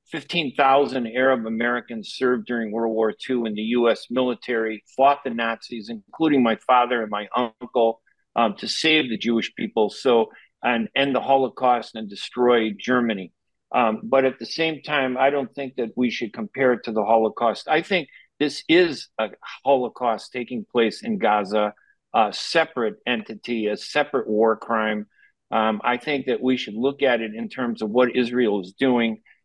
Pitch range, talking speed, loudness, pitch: 110-135 Hz, 175 wpm, -22 LUFS, 120 Hz